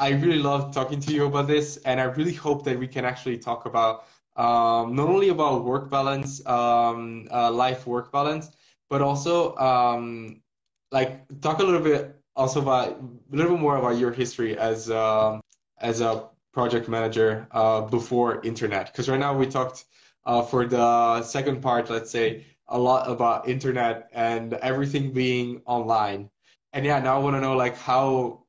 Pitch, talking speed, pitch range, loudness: 125 Hz, 175 wpm, 115-140 Hz, -24 LUFS